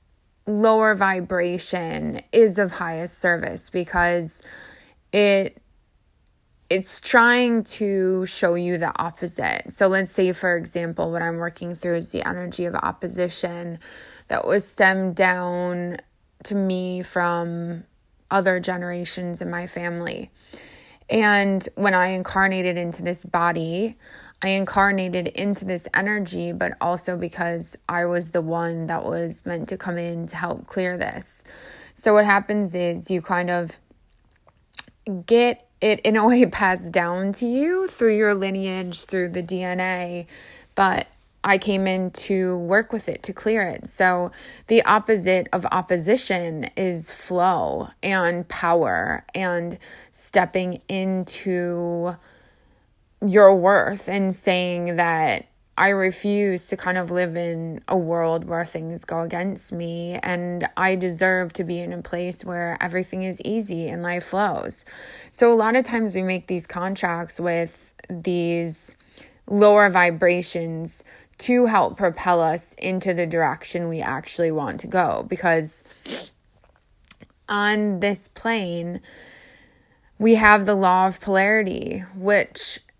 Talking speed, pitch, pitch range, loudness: 135 wpm, 180 Hz, 175-195 Hz, -22 LUFS